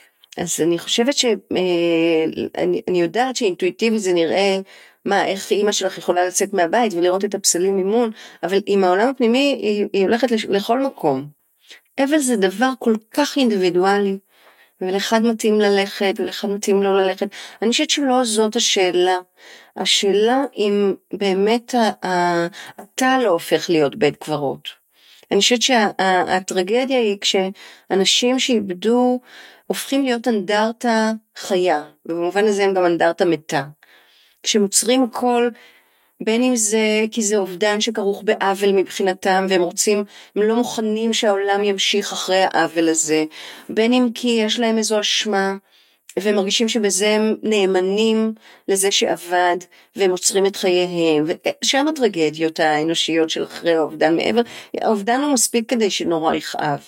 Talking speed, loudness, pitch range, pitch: 130 wpm, -18 LUFS, 180-230 Hz, 200 Hz